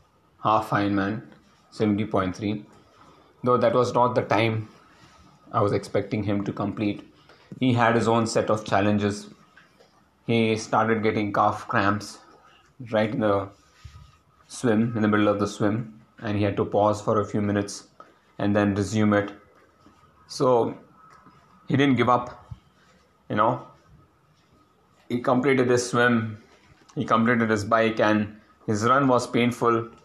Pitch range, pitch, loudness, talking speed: 105-120 Hz, 110 Hz, -24 LUFS, 140 wpm